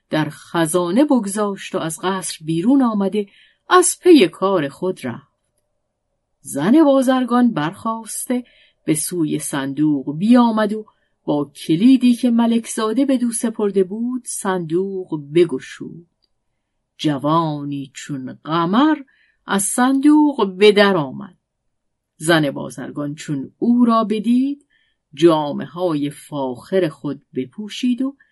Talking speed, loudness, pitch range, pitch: 110 wpm, -18 LUFS, 150-245 Hz, 190 Hz